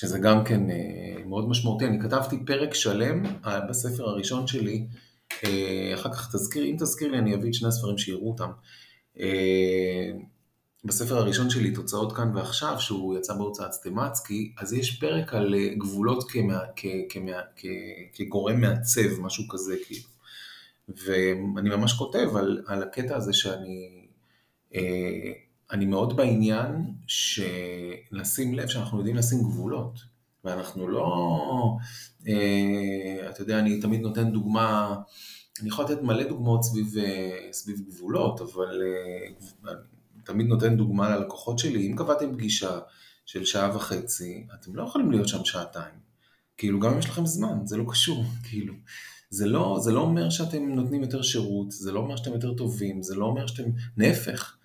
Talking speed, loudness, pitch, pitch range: 145 wpm, -27 LUFS, 110 Hz, 100-120 Hz